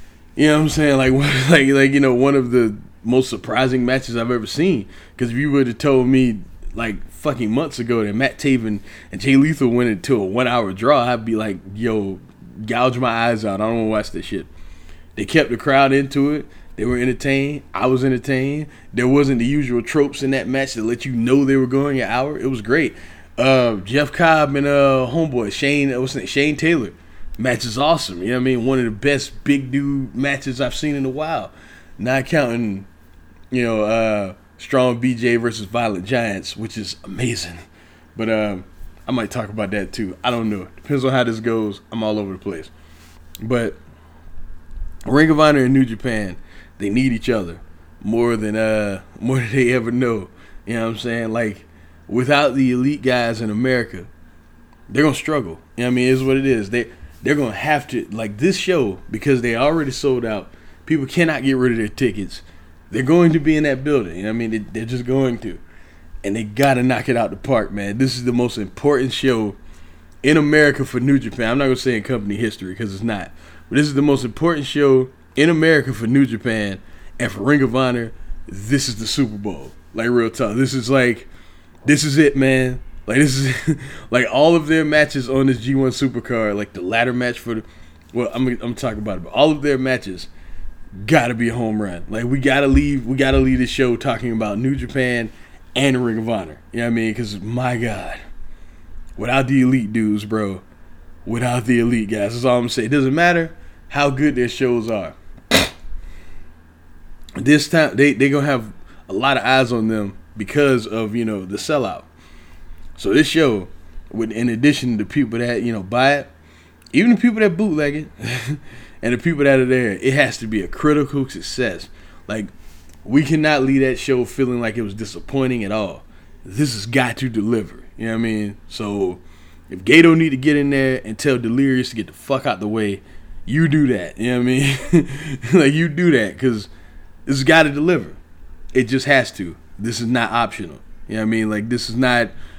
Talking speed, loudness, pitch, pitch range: 215 wpm, -18 LUFS, 120 Hz, 100-135 Hz